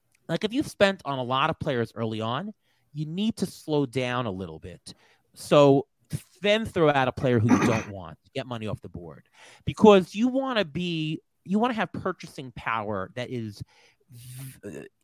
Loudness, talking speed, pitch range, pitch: -25 LUFS, 190 wpm, 120-175 Hz, 135 Hz